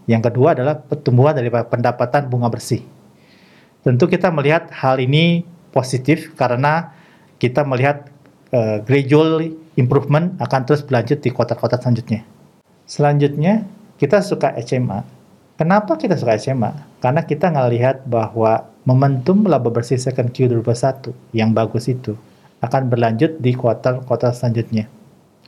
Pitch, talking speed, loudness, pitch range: 130 Hz, 120 wpm, -17 LUFS, 120-150 Hz